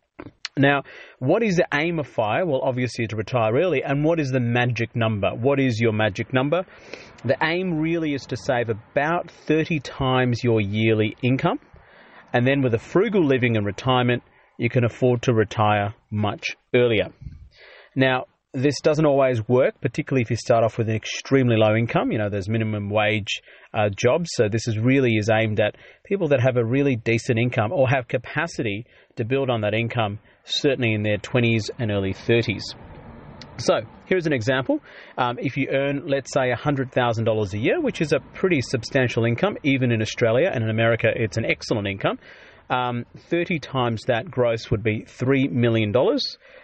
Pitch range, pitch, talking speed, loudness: 115-140 Hz, 125 Hz, 180 wpm, -22 LUFS